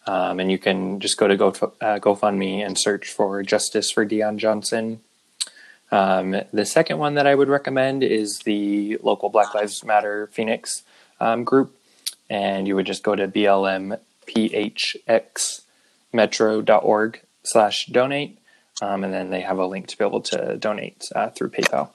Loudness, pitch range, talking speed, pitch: -21 LUFS, 100-110 Hz, 160 wpm, 105 Hz